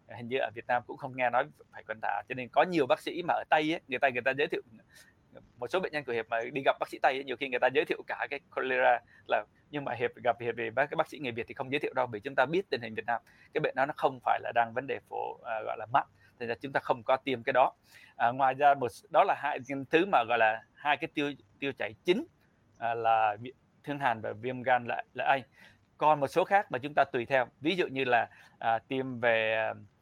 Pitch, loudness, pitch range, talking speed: 125 Hz, -31 LUFS, 115-145 Hz, 285 wpm